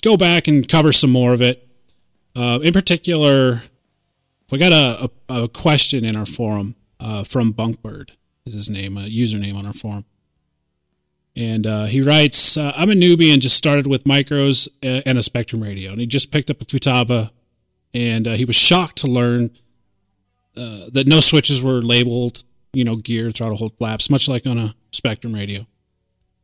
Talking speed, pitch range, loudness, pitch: 185 wpm, 110-140 Hz, -15 LUFS, 120 Hz